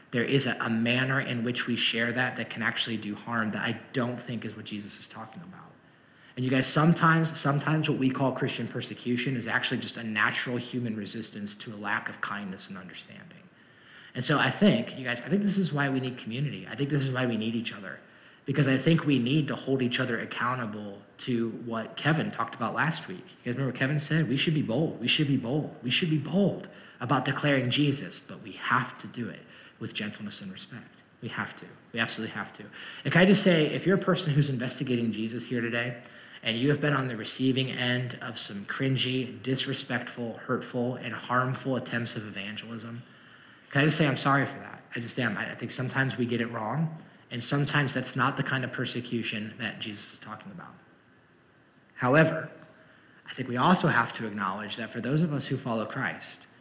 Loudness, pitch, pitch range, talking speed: -28 LUFS, 130 Hz, 120-145 Hz, 215 wpm